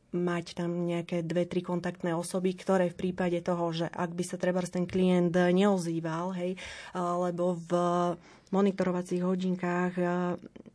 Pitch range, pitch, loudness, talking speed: 175-185 Hz, 180 Hz, -30 LUFS, 135 wpm